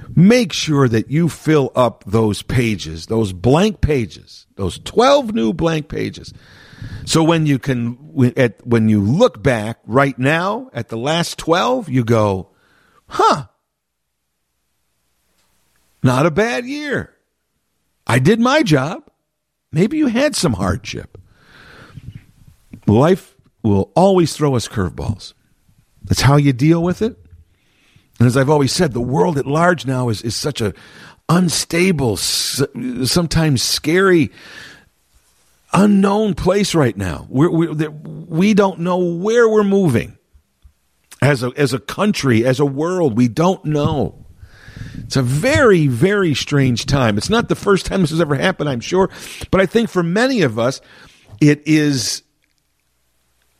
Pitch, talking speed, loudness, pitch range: 145 Hz, 140 wpm, -16 LUFS, 115-175 Hz